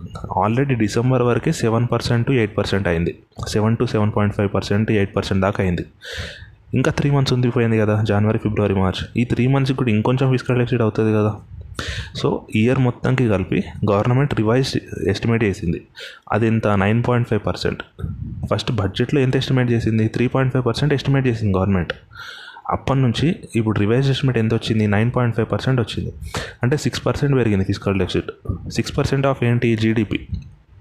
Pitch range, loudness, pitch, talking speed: 100-125 Hz, -19 LUFS, 110 Hz, 160 wpm